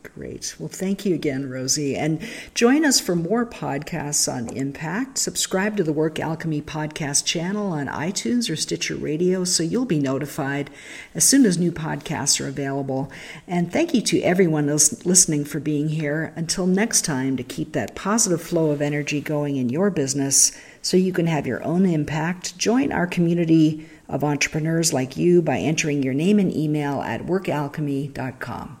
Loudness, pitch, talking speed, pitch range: -21 LUFS, 155 Hz, 170 wpm, 145-185 Hz